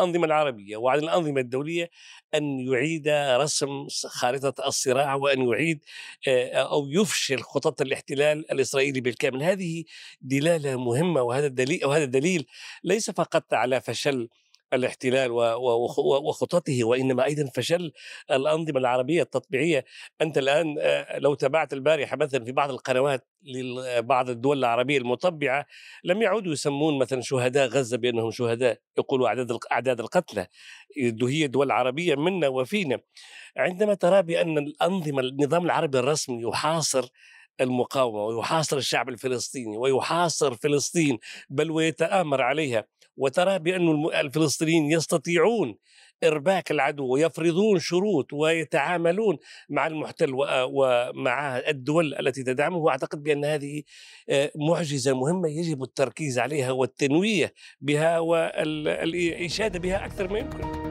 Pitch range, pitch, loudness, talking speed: 130-165 Hz, 145 Hz, -25 LUFS, 110 wpm